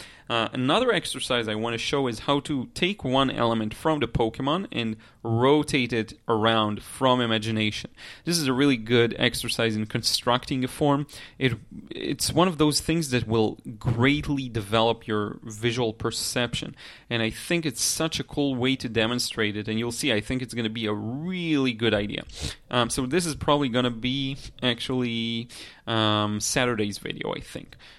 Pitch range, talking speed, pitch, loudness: 115-140 Hz, 180 wpm, 120 Hz, -25 LUFS